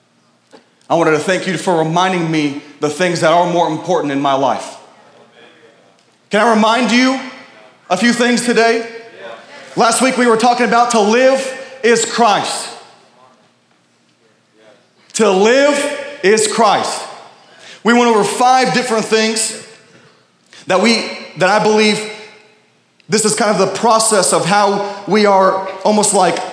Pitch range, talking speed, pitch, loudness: 175-235 Hz, 140 wpm, 210 Hz, -13 LUFS